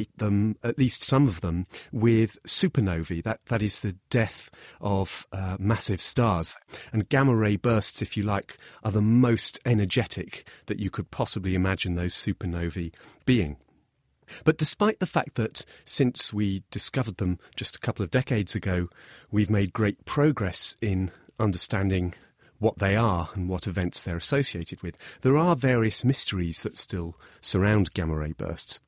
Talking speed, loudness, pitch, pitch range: 160 wpm, -26 LUFS, 105 Hz, 90-115 Hz